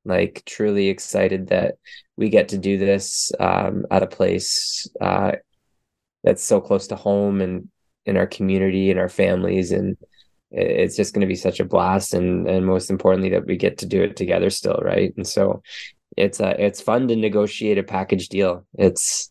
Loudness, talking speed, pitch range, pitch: -20 LUFS, 185 wpm, 95-100 Hz, 95 Hz